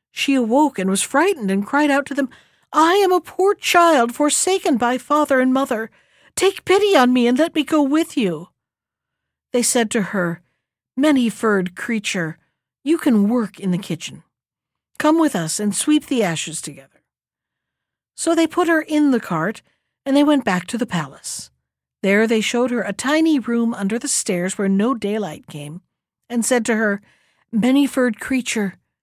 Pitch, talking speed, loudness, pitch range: 240 Hz, 180 wpm, -18 LUFS, 200-295 Hz